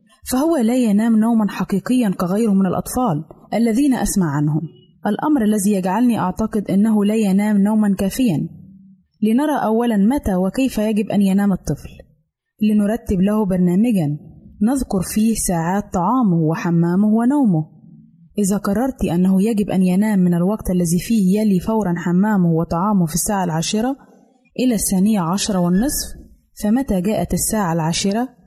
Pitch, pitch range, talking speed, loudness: 205 Hz, 185-220 Hz, 130 wpm, -18 LUFS